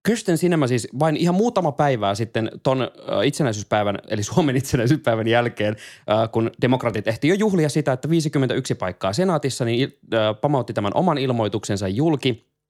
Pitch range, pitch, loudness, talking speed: 110-155 Hz, 130 Hz, -21 LUFS, 140 wpm